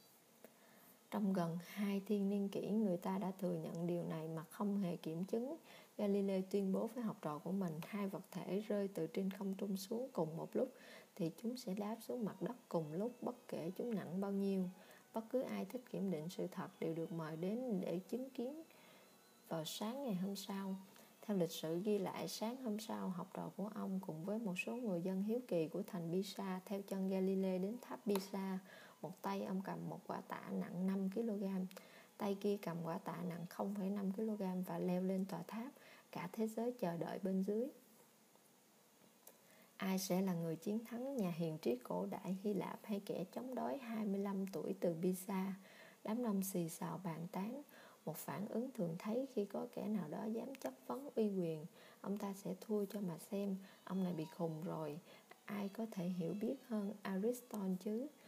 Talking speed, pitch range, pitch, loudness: 200 wpm, 180-220 Hz, 195 Hz, -43 LUFS